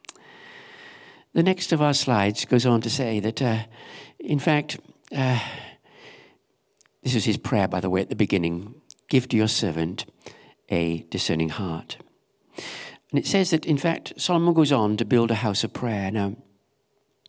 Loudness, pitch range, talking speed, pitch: -24 LUFS, 100-150 Hz, 165 wpm, 120 Hz